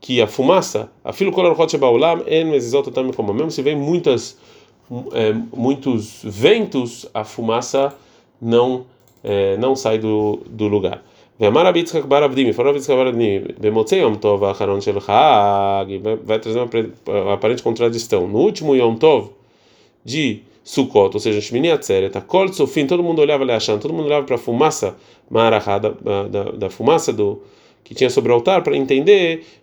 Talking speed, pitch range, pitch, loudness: 170 wpm, 110-160 Hz, 130 Hz, -17 LUFS